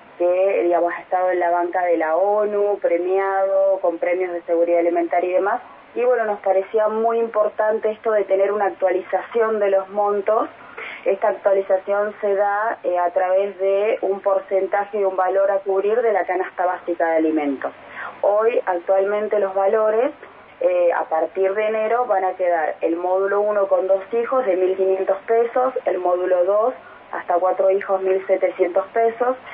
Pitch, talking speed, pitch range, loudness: 195 Hz, 165 wpm, 185-210 Hz, -20 LUFS